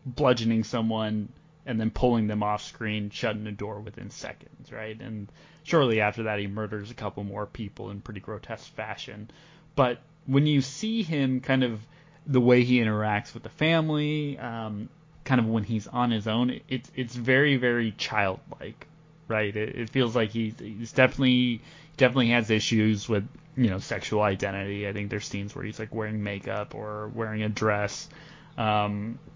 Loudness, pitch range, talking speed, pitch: -27 LUFS, 105-130 Hz, 175 wpm, 115 Hz